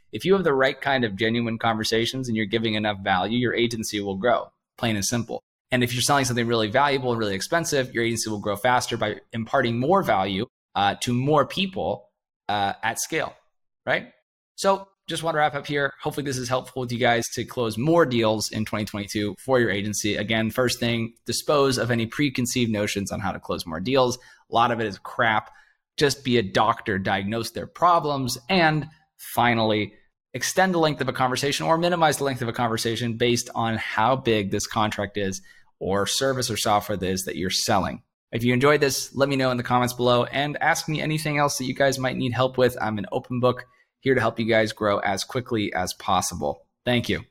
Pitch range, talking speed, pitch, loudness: 110-135 Hz, 215 wpm, 120 Hz, -24 LUFS